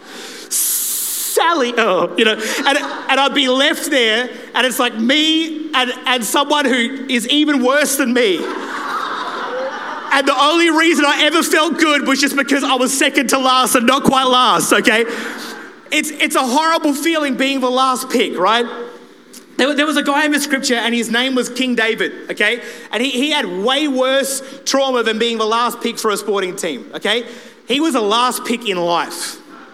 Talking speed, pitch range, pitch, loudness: 190 wpm, 240-290 Hz, 260 Hz, -15 LUFS